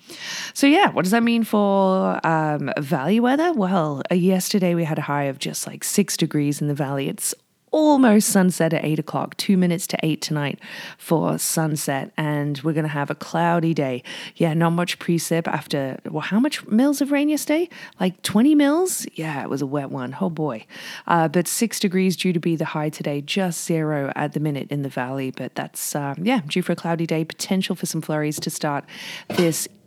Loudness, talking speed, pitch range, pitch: -21 LUFS, 210 wpm, 150-195 Hz, 165 Hz